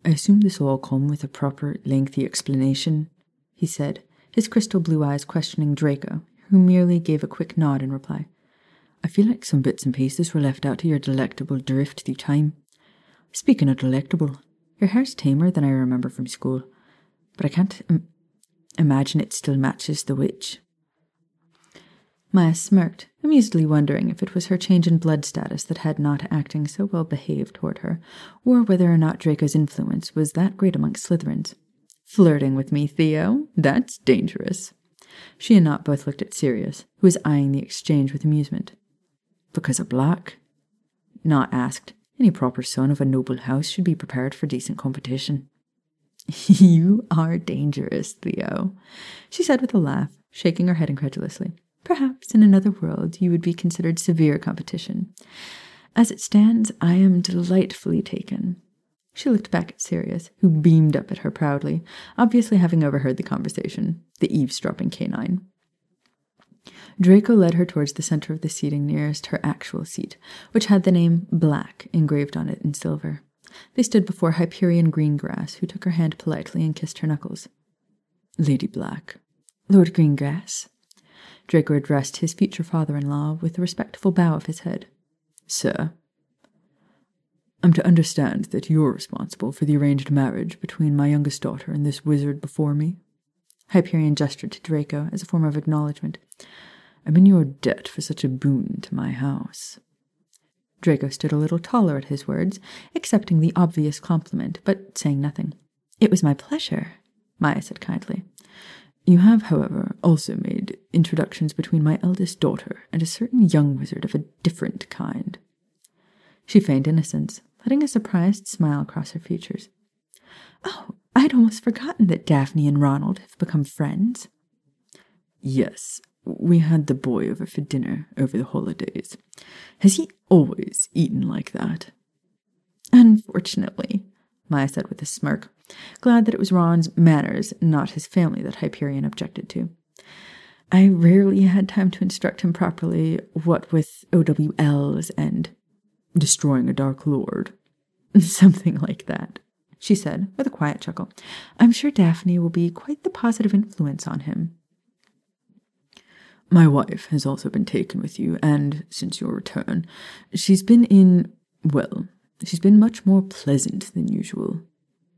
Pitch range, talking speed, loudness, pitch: 150-200 Hz, 160 wpm, -21 LUFS, 175 Hz